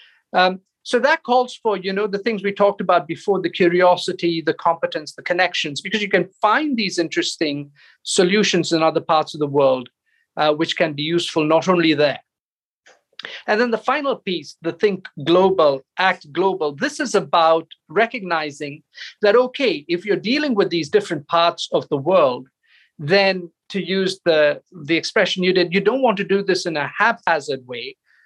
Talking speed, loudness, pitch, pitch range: 180 wpm, -19 LUFS, 180 Hz, 165-205 Hz